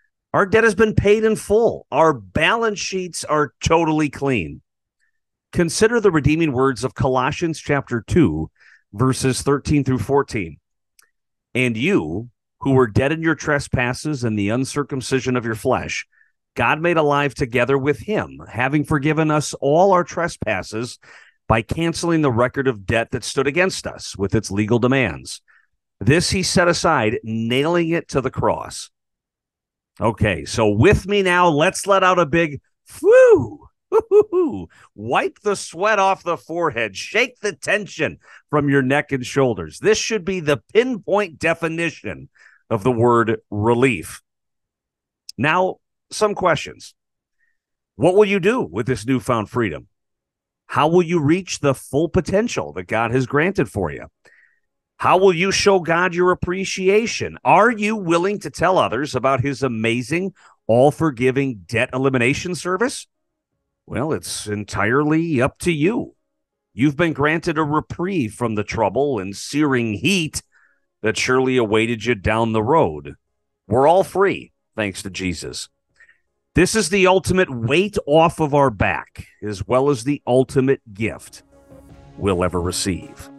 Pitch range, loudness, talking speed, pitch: 115-175 Hz, -19 LUFS, 145 wpm, 140 Hz